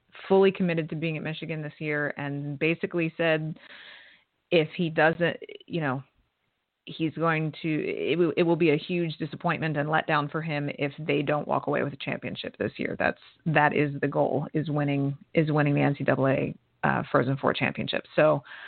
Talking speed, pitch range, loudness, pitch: 185 wpm, 145-165 Hz, -27 LUFS, 155 Hz